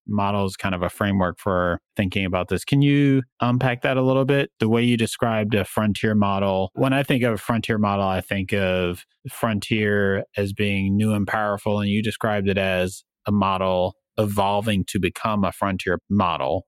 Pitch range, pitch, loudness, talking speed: 95-115 Hz, 100 Hz, -22 LUFS, 185 wpm